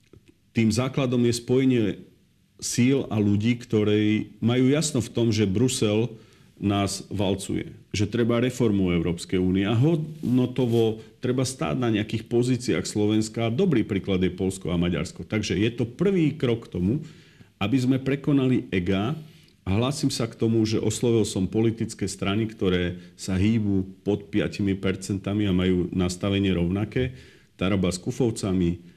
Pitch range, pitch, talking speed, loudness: 95-125 Hz, 110 Hz, 140 wpm, -25 LUFS